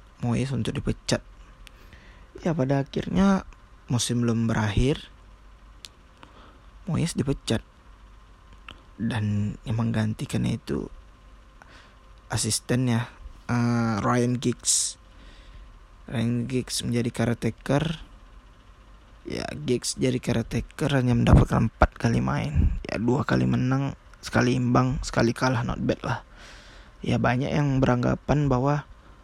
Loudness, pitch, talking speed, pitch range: -25 LUFS, 115 Hz, 100 wpm, 105-125 Hz